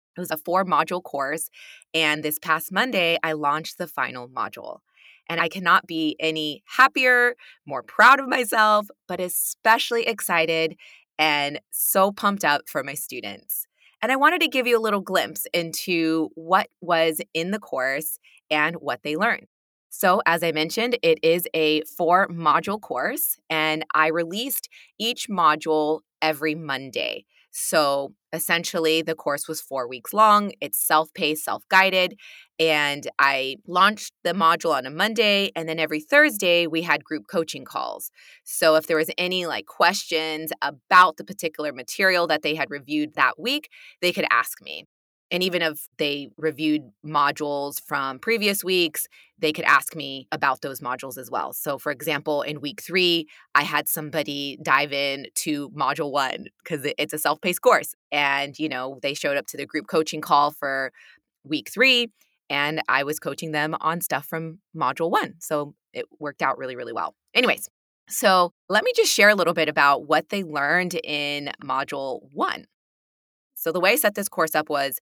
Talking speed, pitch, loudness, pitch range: 170 wpm, 160 Hz, -22 LUFS, 150-185 Hz